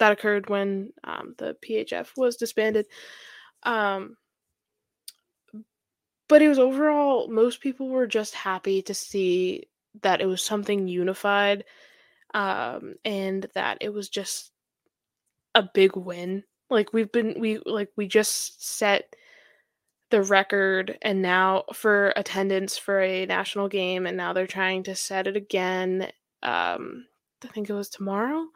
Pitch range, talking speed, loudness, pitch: 190-225 Hz, 140 wpm, -25 LUFS, 205 Hz